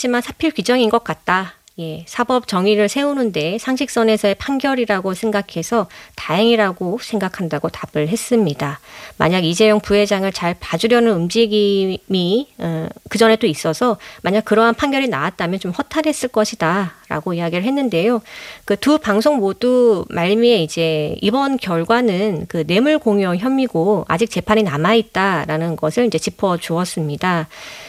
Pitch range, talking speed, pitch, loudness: 175-235 Hz, 325 characters per minute, 210 Hz, -17 LUFS